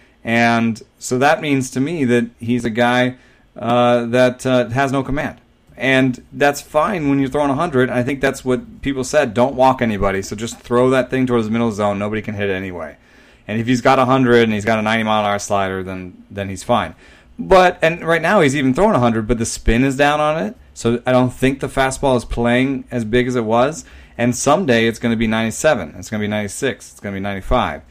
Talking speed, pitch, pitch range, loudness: 230 wpm, 125 Hz, 115-135 Hz, -17 LUFS